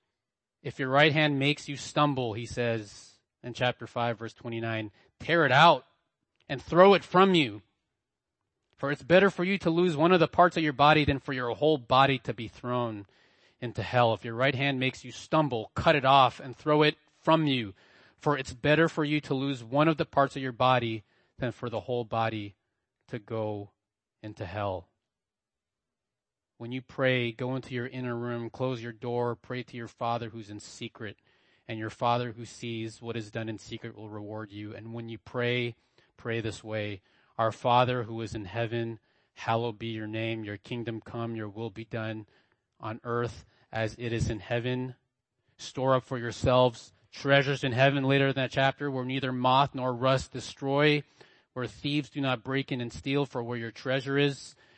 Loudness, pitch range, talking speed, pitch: -28 LUFS, 115-135 Hz, 195 wpm, 120 Hz